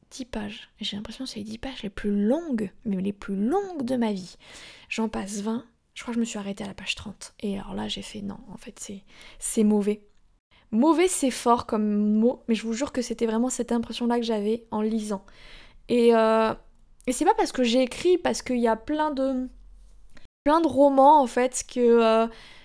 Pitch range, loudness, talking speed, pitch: 210-255 Hz, -25 LUFS, 225 wpm, 230 Hz